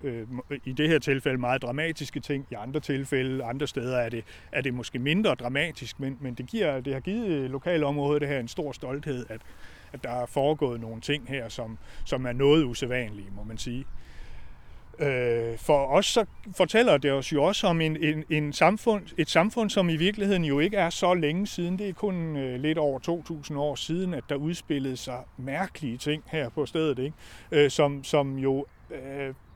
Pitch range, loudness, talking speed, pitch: 130-160 Hz, -27 LUFS, 190 wpm, 140 Hz